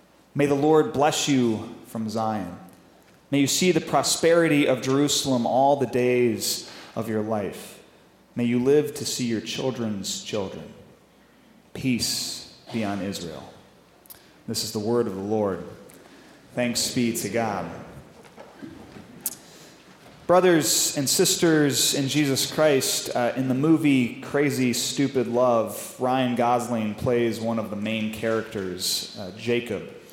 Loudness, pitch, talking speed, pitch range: -23 LUFS, 120 Hz, 130 wpm, 110-140 Hz